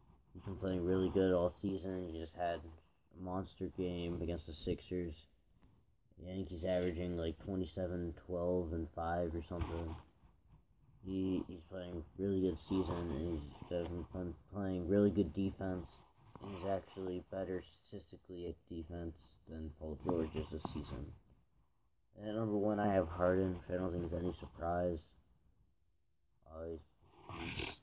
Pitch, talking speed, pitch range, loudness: 90 Hz, 140 wpm, 85-95 Hz, -40 LUFS